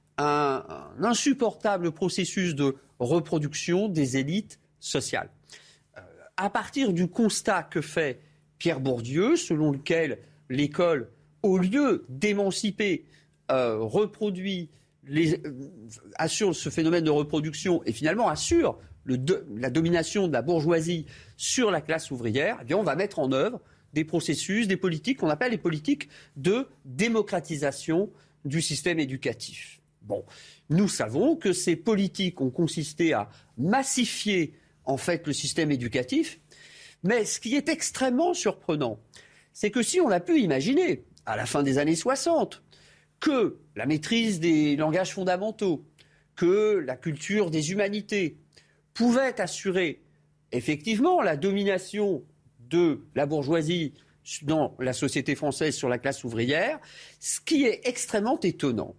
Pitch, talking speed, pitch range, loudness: 170 Hz, 135 wpm, 145-205 Hz, -27 LUFS